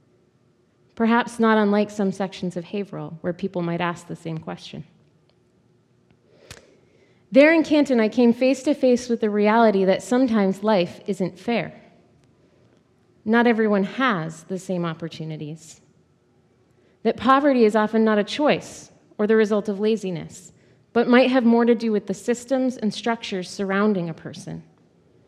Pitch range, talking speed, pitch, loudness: 180-235 Hz, 145 wpm, 210 Hz, -21 LUFS